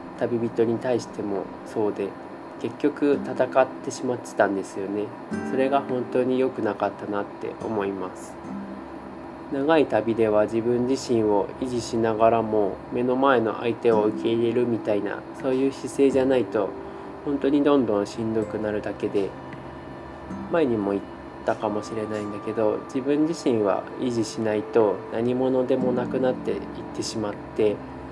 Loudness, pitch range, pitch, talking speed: -25 LUFS, 105-130 Hz, 115 Hz, 330 characters per minute